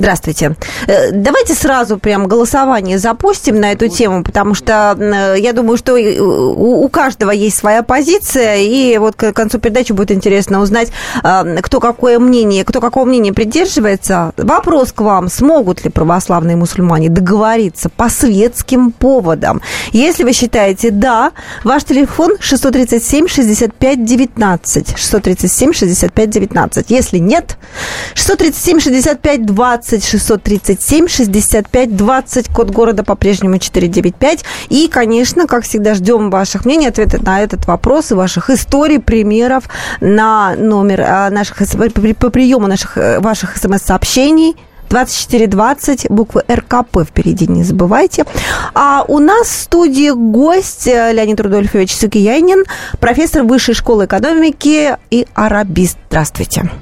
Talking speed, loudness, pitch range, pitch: 125 wpm, -10 LUFS, 200-260 Hz, 225 Hz